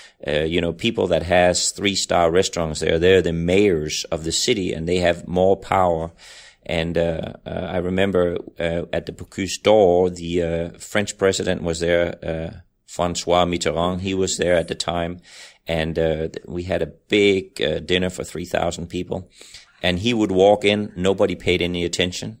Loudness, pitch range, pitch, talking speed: -21 LUFS, 85-95 Hz, 90 Hz, 175 wpm